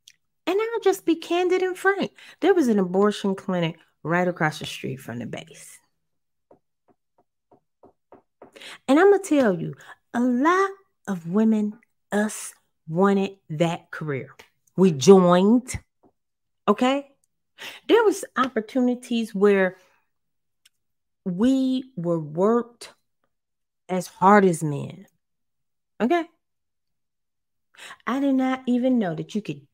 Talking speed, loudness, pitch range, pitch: 115 wpm, -22 LUFS, 185-270 Hz, 210 Hz